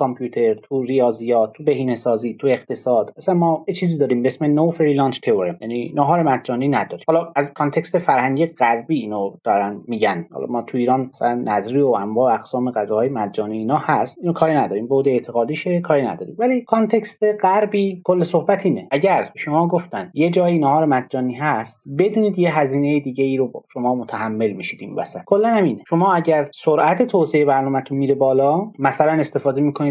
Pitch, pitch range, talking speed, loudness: 145 Hz, 125-170 Hz, 175 wpm, -19 LUFS